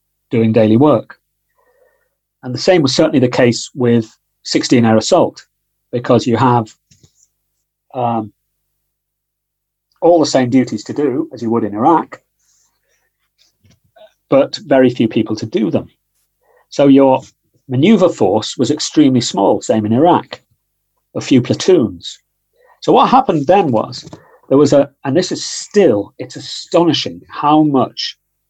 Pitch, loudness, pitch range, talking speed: 130 Hz, -13 LUFS, 120-160 Hz, 135 wpm